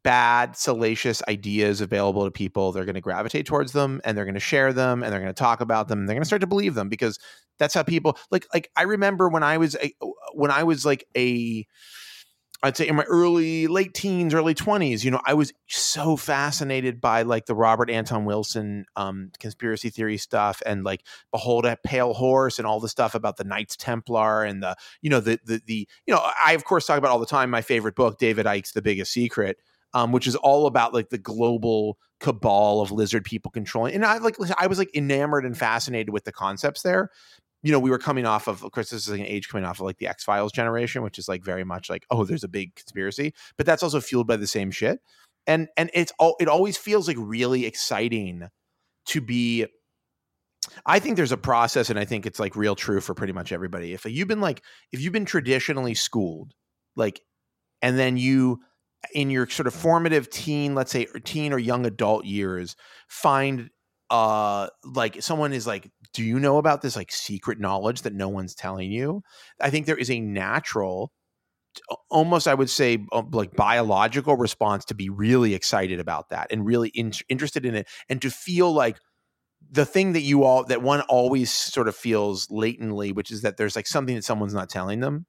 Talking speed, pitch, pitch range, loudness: 215 wpm, 120 Hz, 105-145 Hz, -24 LUFS